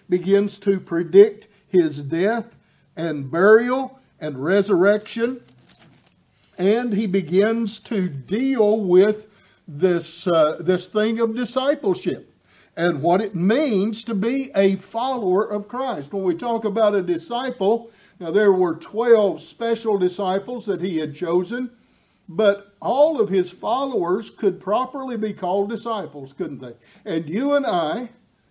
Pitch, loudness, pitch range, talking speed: 205 Hz, -21 LUFS, 180-230 Hz, 135 wpm